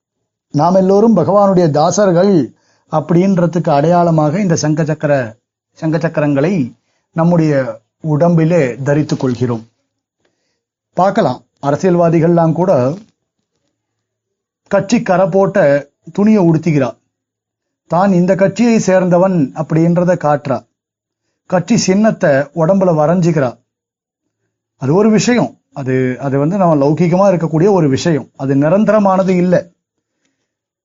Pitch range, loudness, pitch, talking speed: 140-185 Hz, -13 LUFS, 165 Hz, 90 wpm